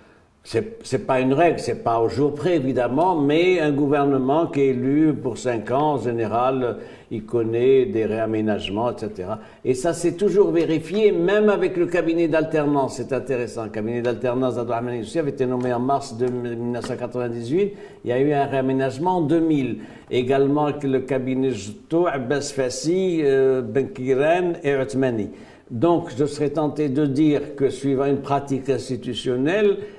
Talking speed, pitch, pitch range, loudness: 160 wpm, 135 Hz, 125-155 Hz, -21 LUFS